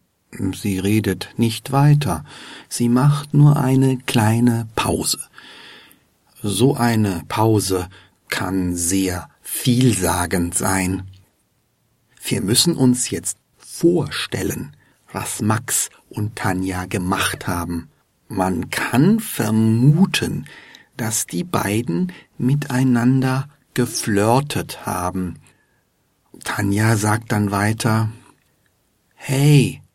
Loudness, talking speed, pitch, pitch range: -19 LUFS, 85 wpm, 110 Hz, 95-130 Hz